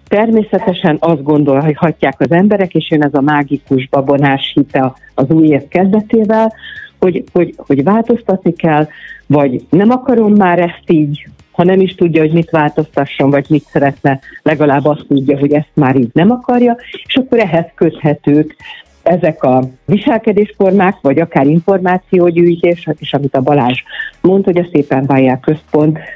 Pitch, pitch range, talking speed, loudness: 160 Hz, 145-190 Hz, 155 wpm, -11 LUFS